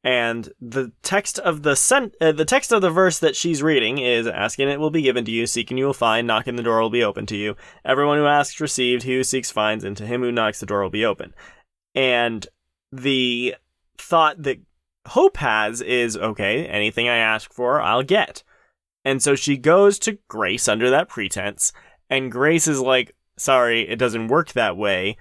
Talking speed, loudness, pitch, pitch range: 205 wpm, -20 LUFS, 125 Hz, 115-145 Hz